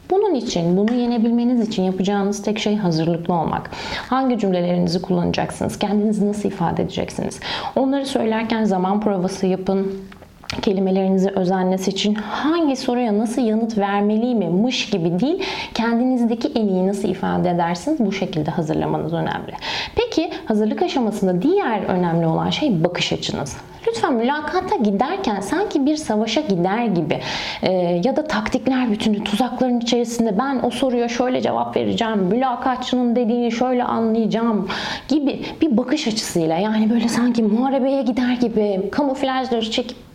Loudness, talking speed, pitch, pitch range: -20 LUFS, 135 wpm, 225 Hz, 195-255 Hz